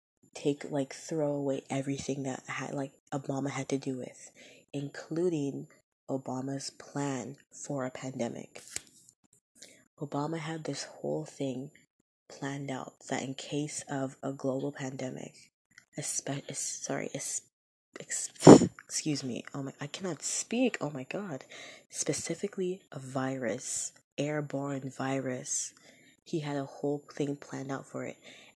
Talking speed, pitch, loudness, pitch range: 125 wpm, 140 Hz, -32 LUFS, 135-145 Hz